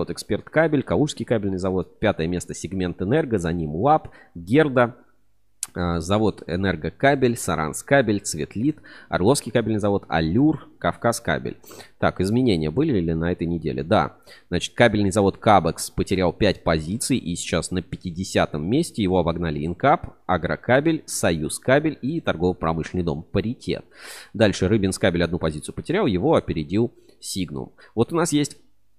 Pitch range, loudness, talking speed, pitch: 85-120 Hz, -22 LUFS, 140 wpm, 95 Hz